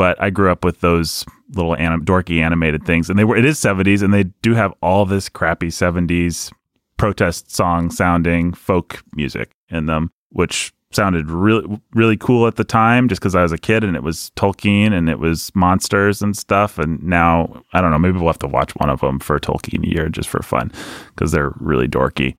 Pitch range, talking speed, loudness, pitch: 85-100 Hz, 210 wpm, -17 LUFS, 90 Hz